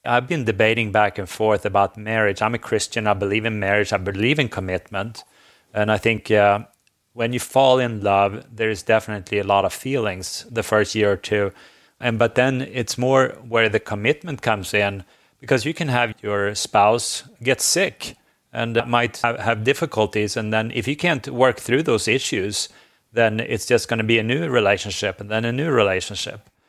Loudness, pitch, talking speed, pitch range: -20 LUFS, 110 Hz, 195 wpm, 105-120 Hz